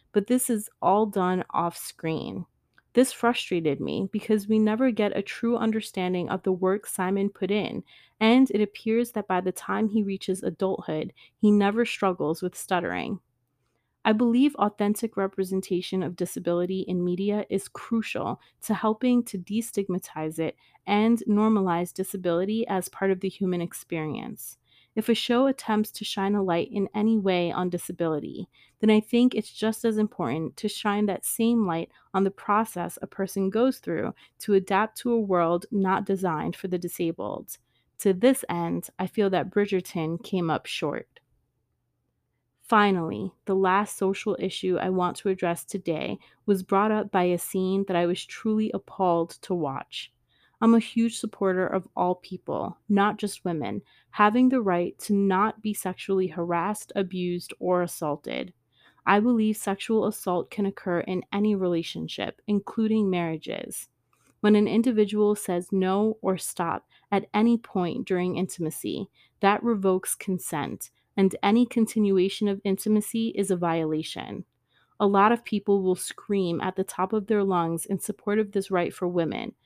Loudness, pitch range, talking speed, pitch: -26 LUFS, 180-215 Hz, 160 wpm, 195 Hz